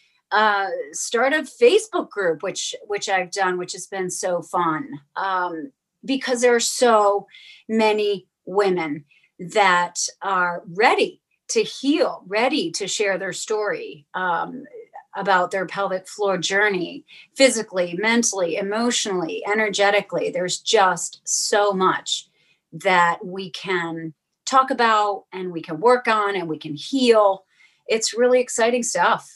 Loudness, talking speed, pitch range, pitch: -21 LUFS, 130 wpm, 180-240 Hz, 200 Hz